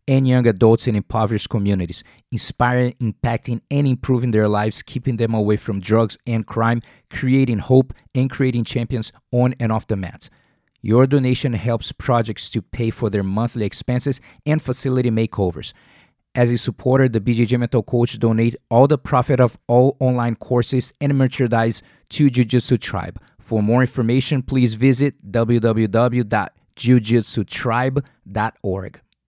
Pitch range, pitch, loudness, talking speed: 110-130 Hz, 120 Hz, -19 LUFS, 140 wpm